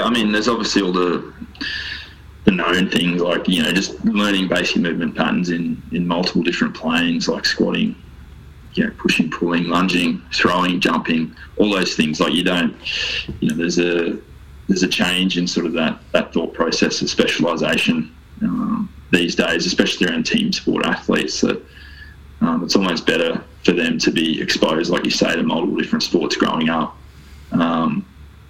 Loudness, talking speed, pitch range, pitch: -18 LUFS, 175 wpm, 75-95 Hz, 85 Hz